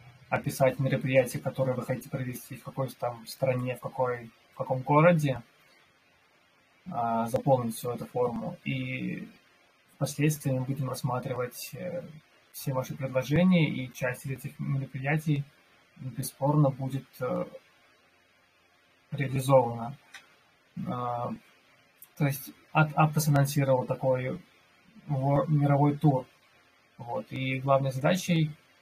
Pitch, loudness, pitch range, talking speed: 135 Hz, -29 LUFS, 125-145 Hz, 100 wpm